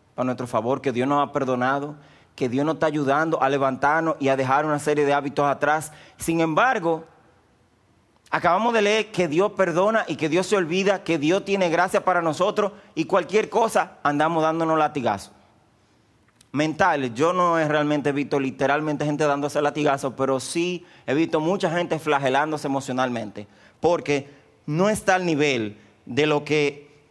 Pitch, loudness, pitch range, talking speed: 150 Hz, -22 LUFS, 135-170 Hz, 170 wpm